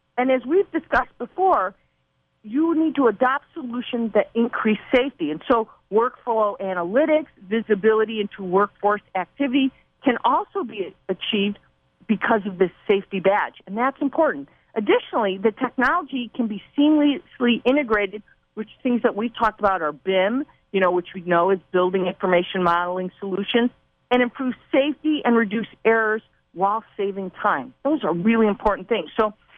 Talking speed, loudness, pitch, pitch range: 150 wpm, -22 LUFS, 225 Hz, 195-260 Hz